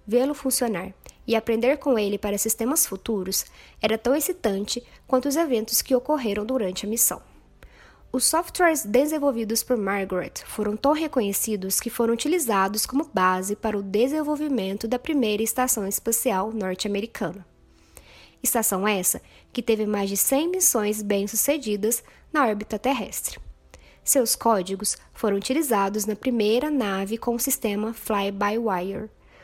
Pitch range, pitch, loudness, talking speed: 205-255 Hz, 225 Hz, -24 LUFS, 130 wpm